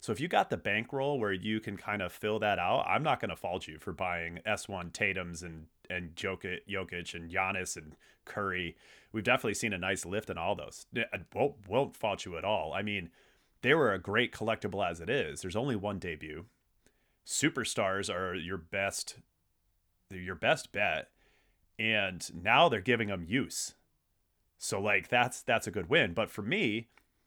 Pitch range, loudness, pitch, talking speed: 85-105 Hz, -32 LUFS, 95 Hz, 185 wpm